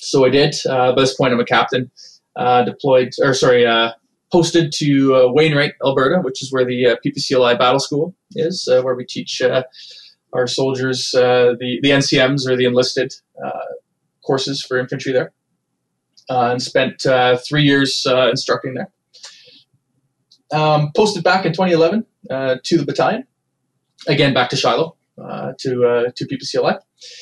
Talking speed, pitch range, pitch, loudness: 165 wpm, 125-150 Hz, 135 Hz, -16 LUFS